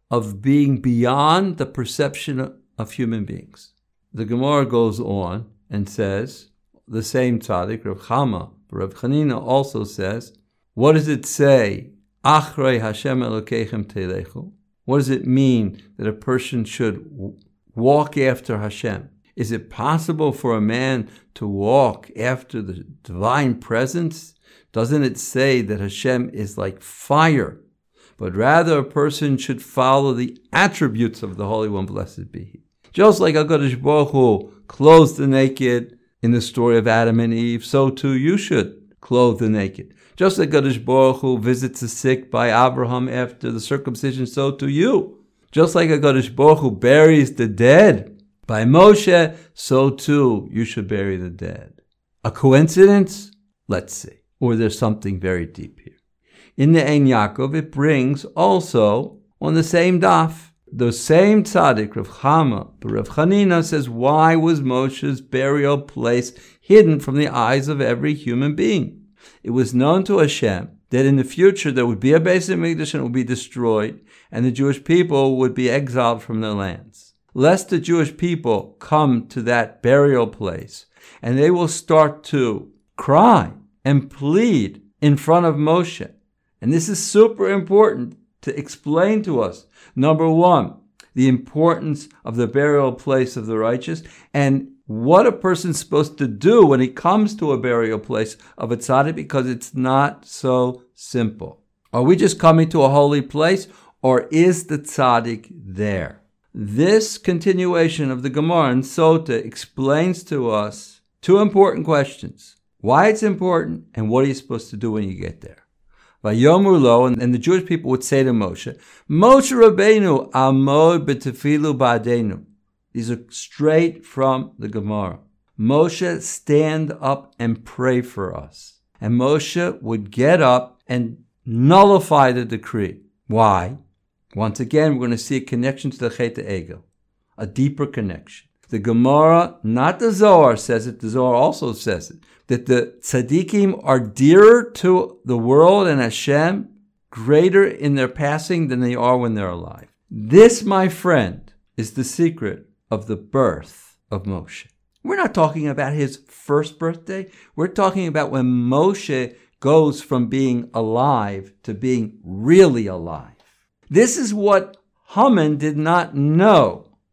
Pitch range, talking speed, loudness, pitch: 115-155 Hz, 155 wpm, -17 LUFS, 135 Hz